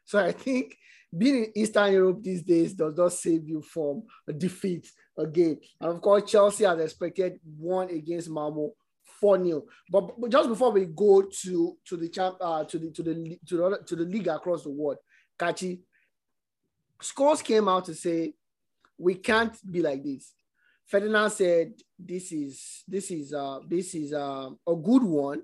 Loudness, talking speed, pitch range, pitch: -27 LUFS, 150 wpm, 160-200 Hz, 175 Hz